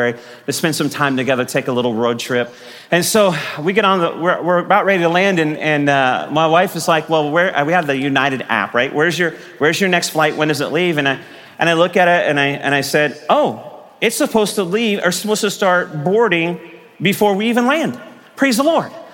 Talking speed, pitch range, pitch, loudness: 240 wpm, 140-190 Hz, 165 Hz, -16 LUFS